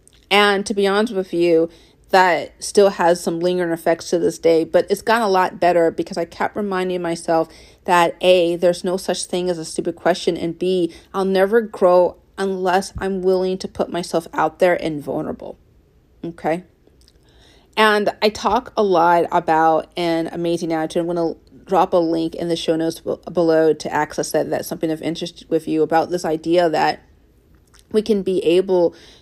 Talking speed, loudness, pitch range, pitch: 185 wpm, -19 LUFS, 165-185 Hz, 175 Hz